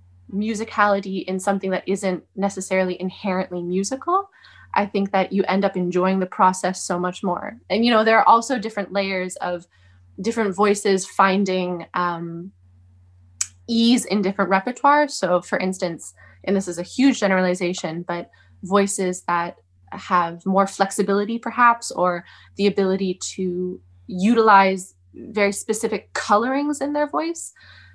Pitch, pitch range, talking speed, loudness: 190 Hz, 180-205 Hz, 135 wpm, -21 LUFS